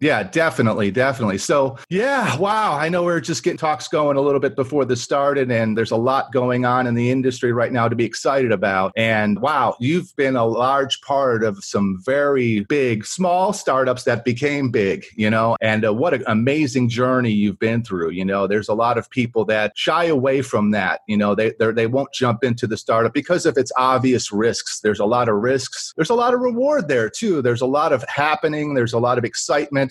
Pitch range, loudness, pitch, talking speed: 115-145 Hz, -19 LUFS, 125 Hz, 225 wpm